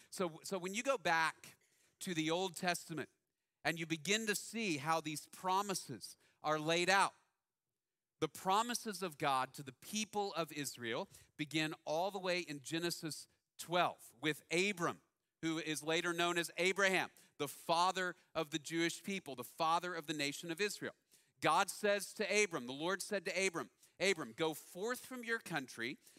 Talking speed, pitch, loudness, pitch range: 165 wpm, 170 Hz, -38 LUFS, 155-190 Hz